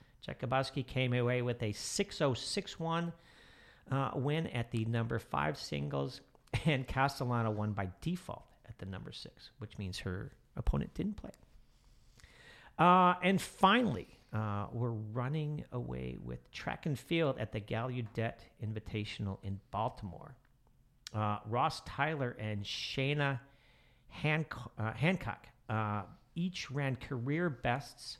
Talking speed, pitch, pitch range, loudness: 130 wpm, 125 Hz, 105-140 Hz, -36 LUFS